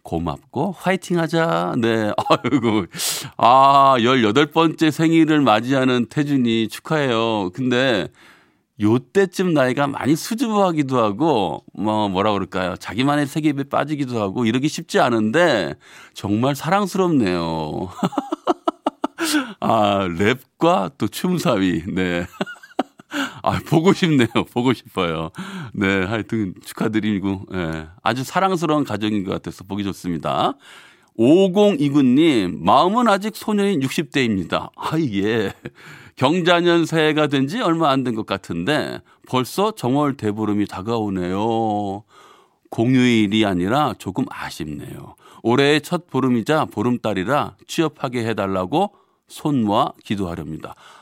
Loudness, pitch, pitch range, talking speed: -19 LUFS, 125 Hz, 105-160 Hz, 260 characters per minute